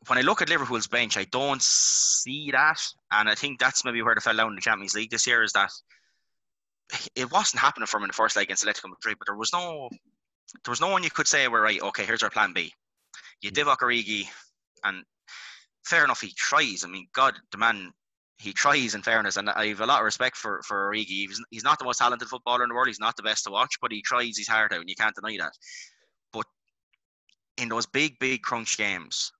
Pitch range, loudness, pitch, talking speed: 105-125 Hz, -25 LUFS, 115 Hz, 240 wpm